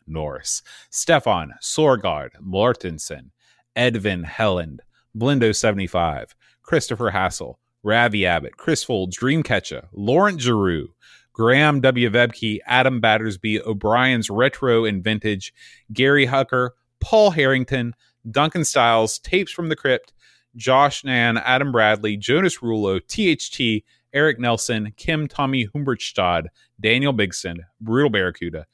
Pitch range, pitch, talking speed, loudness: 105-130 Hz, 115 Hz, 105 wpm, -20 LUFS